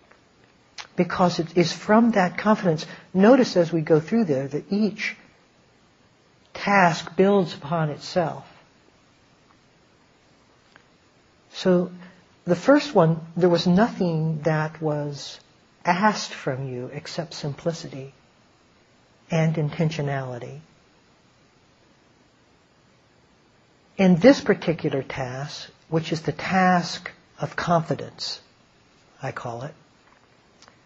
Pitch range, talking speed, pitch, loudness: 150-185 Hz, 90 wpm, 170 Hz, -23 LUFS